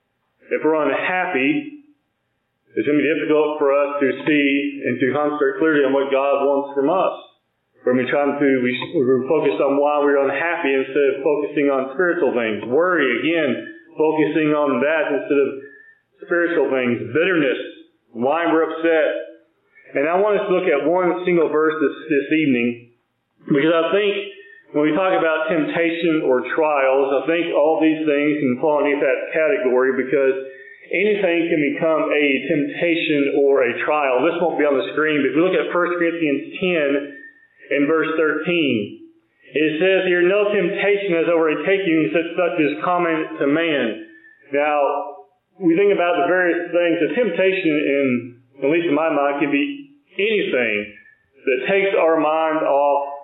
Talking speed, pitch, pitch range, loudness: 170 wpm, 160 Hz, 140-185 Hz, -19 LUFS